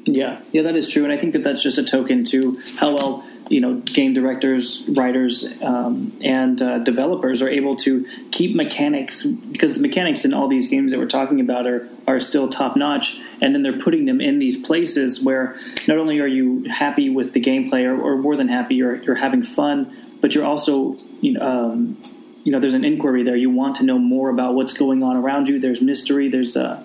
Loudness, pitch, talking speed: -19 LUFS, 155 Hz, 220 wpm